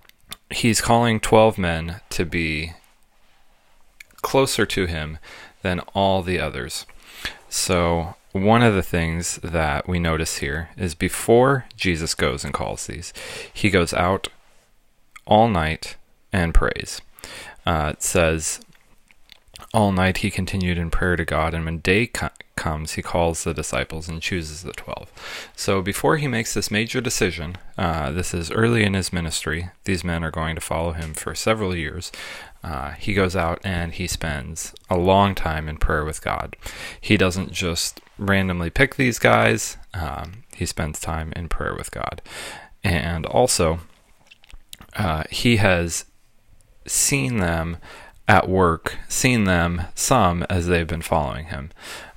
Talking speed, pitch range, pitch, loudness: 150 wpm, 80-100 Hz, 90 Hz, -22 LUFS